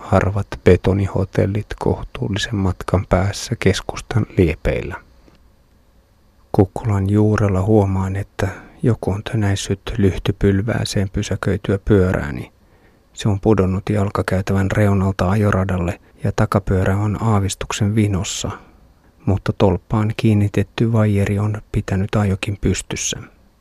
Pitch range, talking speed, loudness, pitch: 95-105 Hz, 90 wpm, -19 LUFS, 100 Hz